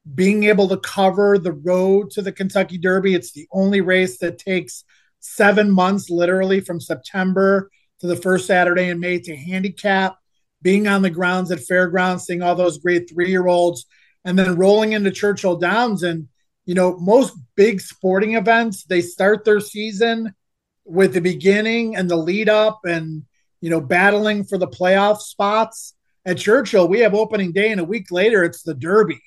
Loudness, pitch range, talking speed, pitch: -18 LUFS, 175-205 Hz, 180 wpm, 185 Hz